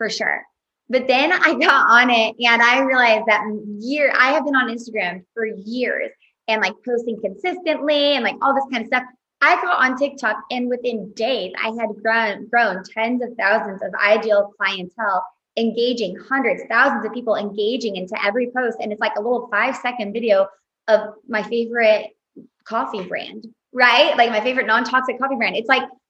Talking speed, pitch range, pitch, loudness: 180 wpm, 215-255 Hz, 230 Hz, -19 LUFS